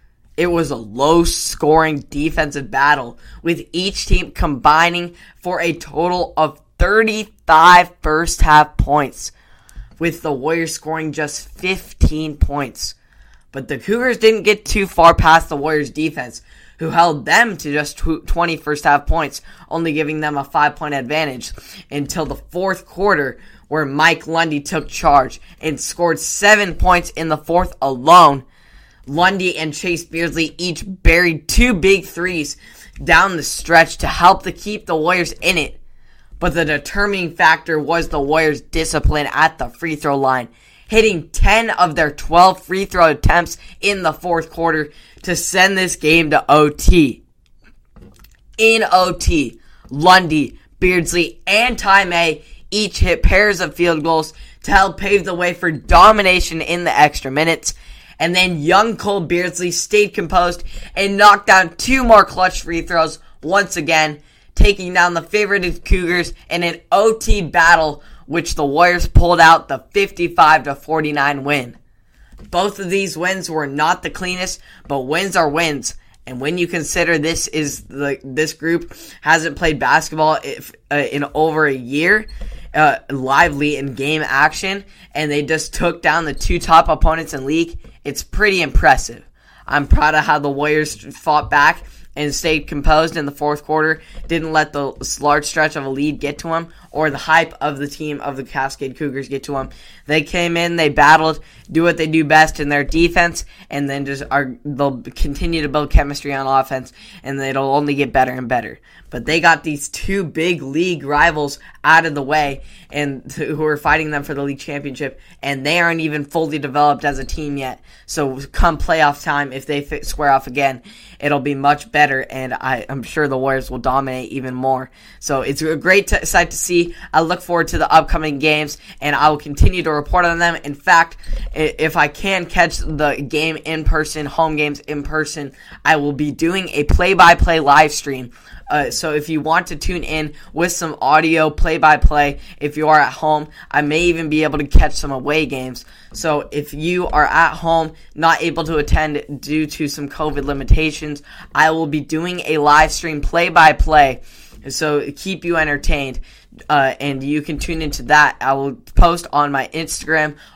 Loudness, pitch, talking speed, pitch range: -16 LUFS, 155 Hz, 175 wpm, 145-170 Hz